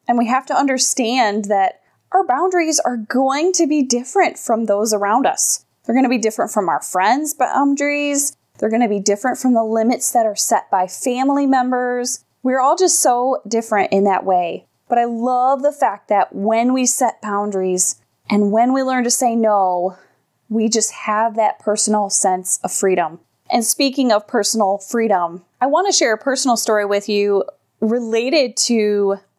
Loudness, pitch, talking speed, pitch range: -17 LUFS, 235 Hz, 175 wpm, 205-260 Hz